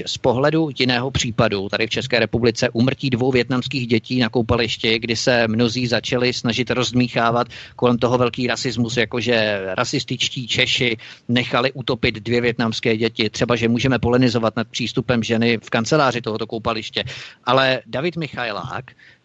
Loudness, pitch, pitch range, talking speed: -19 LUFS, 120 Hz, 115-125 Hz, 145 wpm